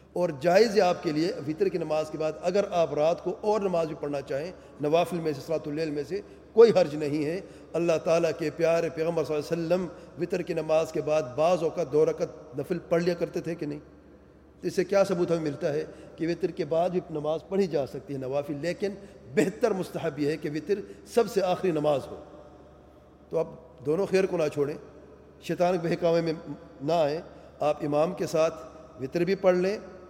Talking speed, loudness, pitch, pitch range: 215 wpm, -28 LUFS, 165 Hz, 155-180 Hz